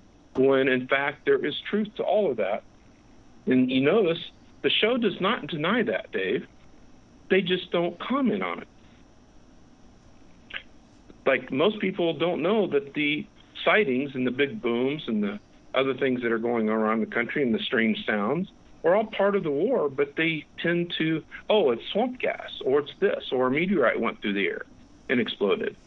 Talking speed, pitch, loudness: 185 wpm, 175 Hz, -25 LUFS